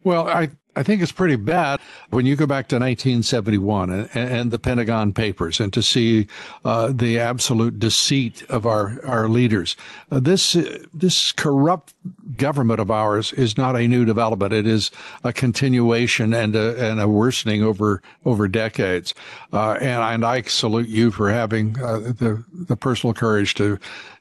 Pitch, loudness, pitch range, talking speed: 115 Hz, -20 LUFS, 110-130 Hz, 170 wpm